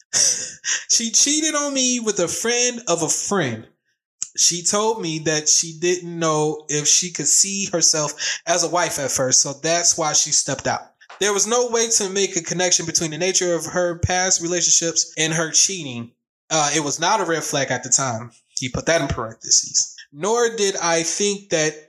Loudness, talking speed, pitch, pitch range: -18 LUFS, 195 wpm, 170 Hz, 155-195 Hz